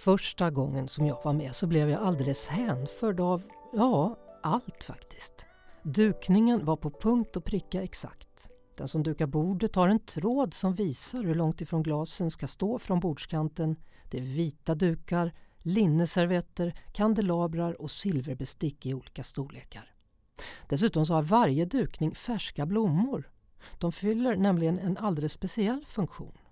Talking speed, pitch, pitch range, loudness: 145 wpm, 170 Hz, 155-205 Hz, -29 LUFS